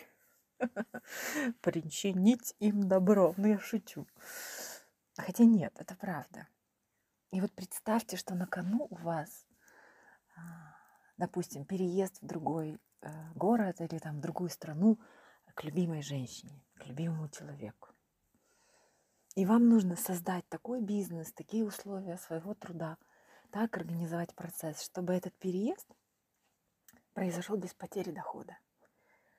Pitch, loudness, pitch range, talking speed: 185 Hz, -34 LUFS, 165-210 Hz, 110 wpm